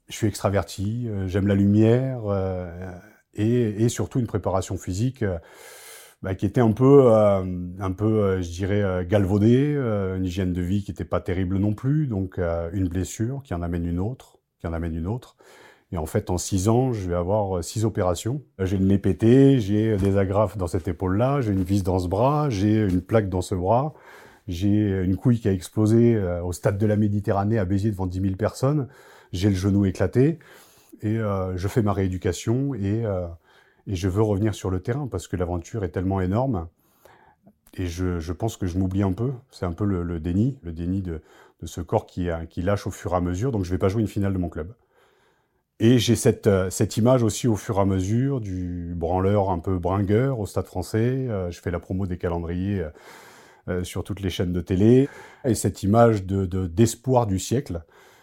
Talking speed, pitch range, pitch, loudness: 220 wpm, 95-110 Hz, 100 Hz, -23 LUFS